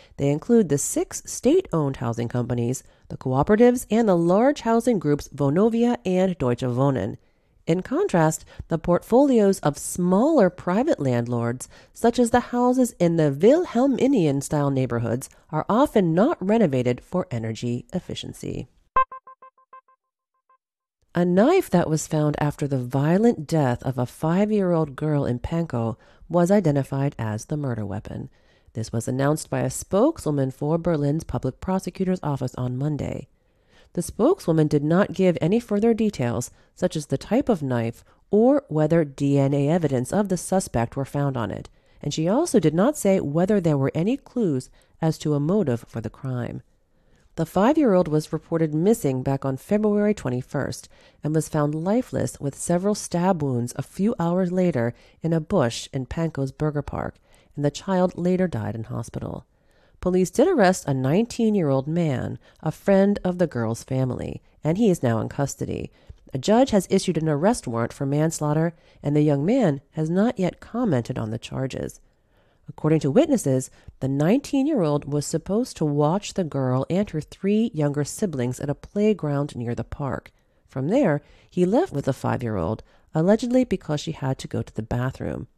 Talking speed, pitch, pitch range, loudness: 170 wpm, 155 Hz, 130-195 Hz, -23 LUFS